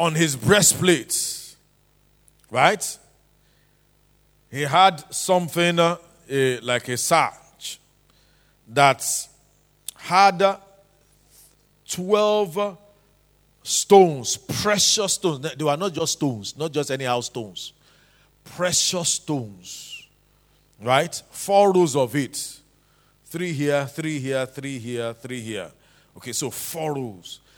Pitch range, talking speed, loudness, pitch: 130-180 Hz, 100 wpm, -21 LUFS, 150 Hz